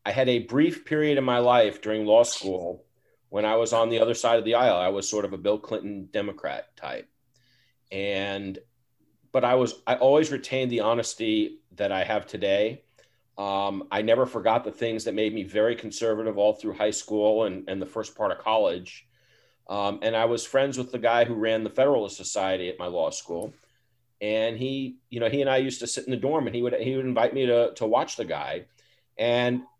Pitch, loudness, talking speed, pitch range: 115 Hz, -25 LUFS, 215 wpm, 105-125 Hz